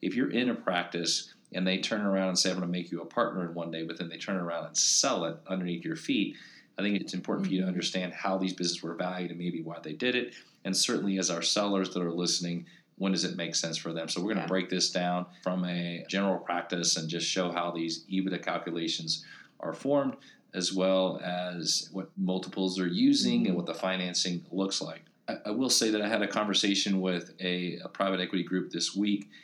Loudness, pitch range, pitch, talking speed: -30 LUFS, 85-95 Hz, 90 Hz, 235 wpm